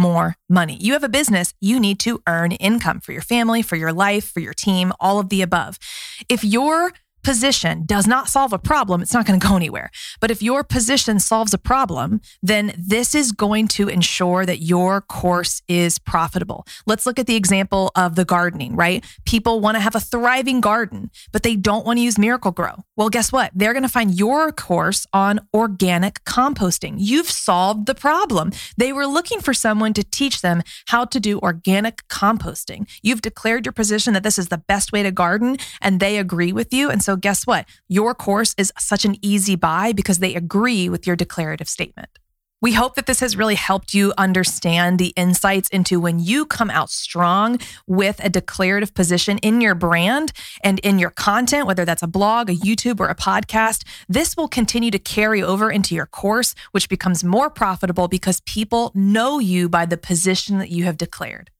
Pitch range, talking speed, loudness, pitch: 185-230 Hz, 200 wpm, -18 LUFS, 200 Hz